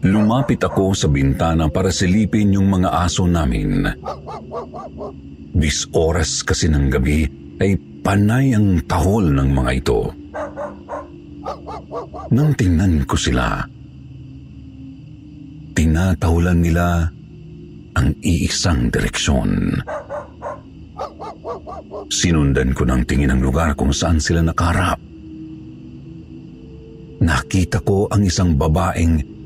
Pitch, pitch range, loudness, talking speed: 85 Hz, 70-100 Hz, -18 LUFS, 95 wpm